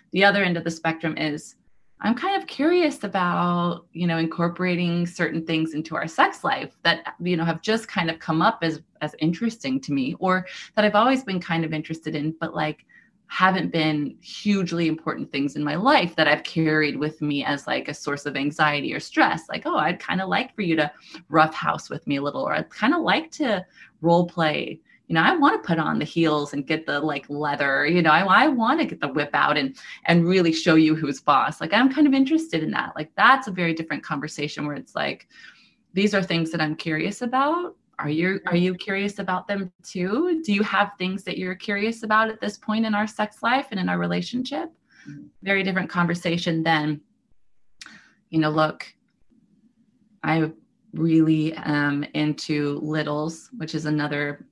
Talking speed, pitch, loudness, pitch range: 205 wpm, 170 Hz, -23 LUFS, 155-205 Hz